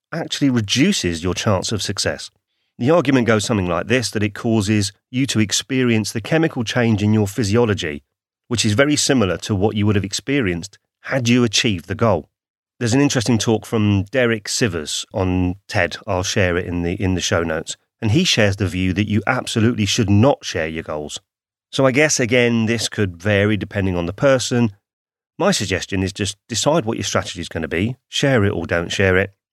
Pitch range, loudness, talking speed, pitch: 95-120 Hz, -18 LUFS, 200 wpm, 105 Hz